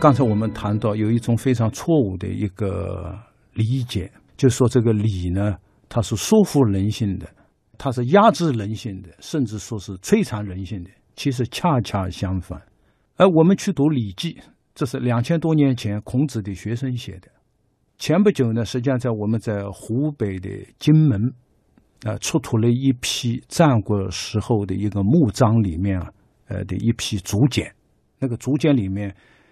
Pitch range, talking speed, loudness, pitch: 100-135 Hz, 250 characters per minute, -21 LUFS, 115 Hz